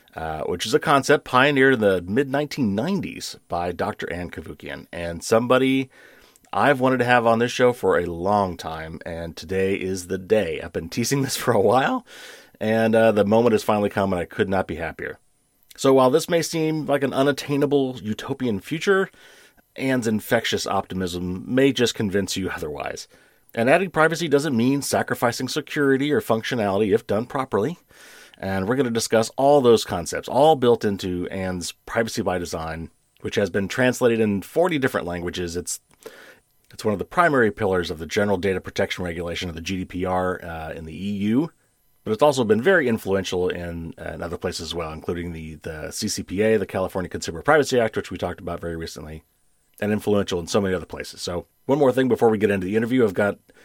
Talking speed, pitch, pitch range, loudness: 190 wpm, 110 Hz, 90-130 Hz, -22 LUFS